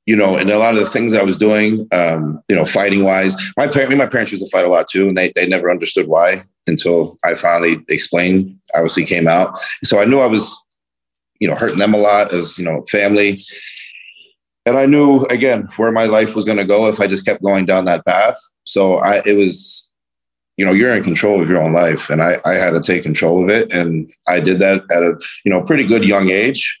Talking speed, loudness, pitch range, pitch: 245 wpm, -14 LUFS, 90-105 Hz, 95 Hz